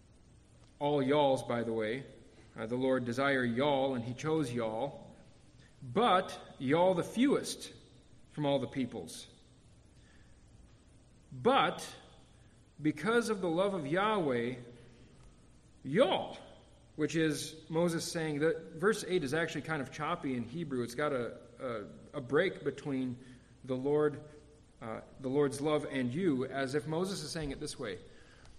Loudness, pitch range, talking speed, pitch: -34 LUFS, 130-160 Hz, 140 wpm, 145 Hz